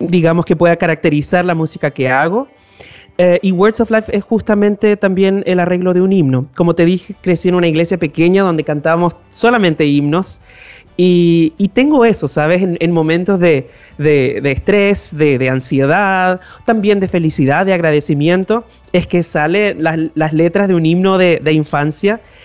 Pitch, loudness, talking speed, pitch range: 175 Hz, -13 LUFS, 175 wpm, 160-195 Hz